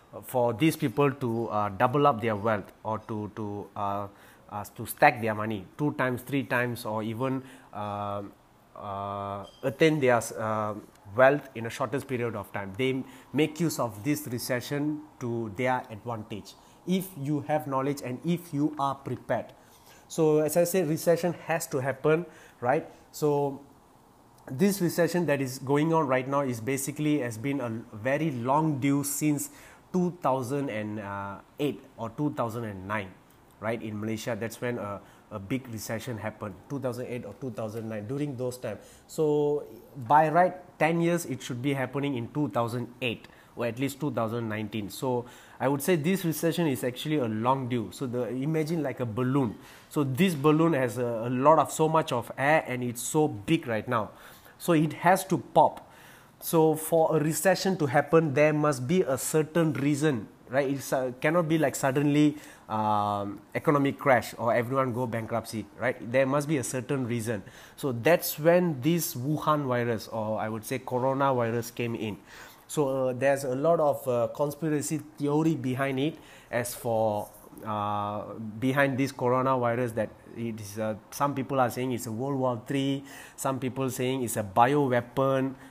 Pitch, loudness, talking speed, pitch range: 130 Hz, -28 LUFS, 165 wpm, 115-150 Hz